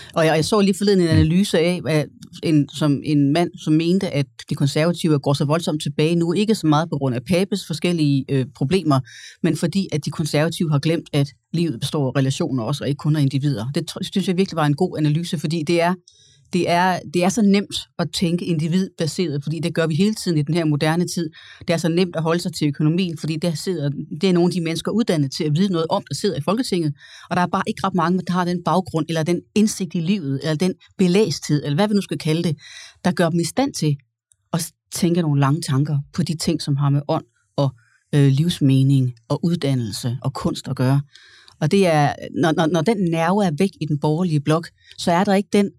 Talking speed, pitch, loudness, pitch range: 235 wpm, 165 Hz, -20 LUFS, 145-180 Hz